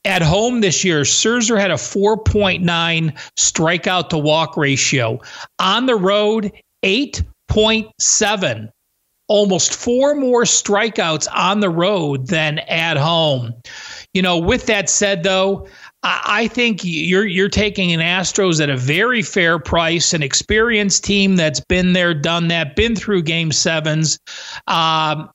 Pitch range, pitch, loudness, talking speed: 160-205 Hz, 180 Hz, -15 LUFS, 135 wpm